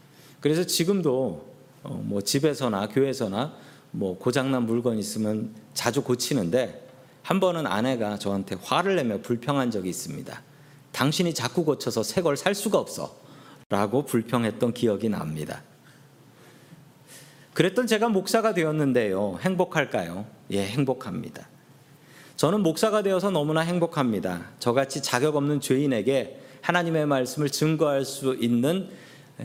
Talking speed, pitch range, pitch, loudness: 295 characters per minute, 120-160 Hz, 140 Hz, -25 LUFS